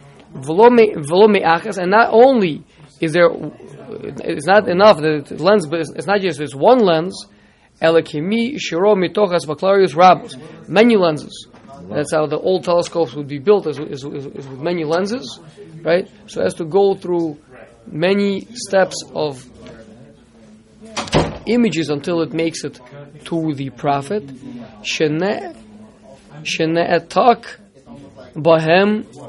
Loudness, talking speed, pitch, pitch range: -16 LUFS, 120 wpm, 165 Hz, 150-200 Hz